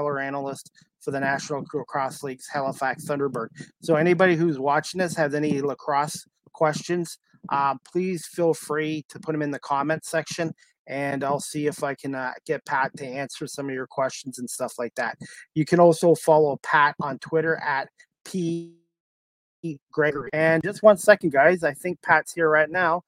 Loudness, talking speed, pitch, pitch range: -24 LUFS, 175 wpm, 150 Hz, 140-170 Hz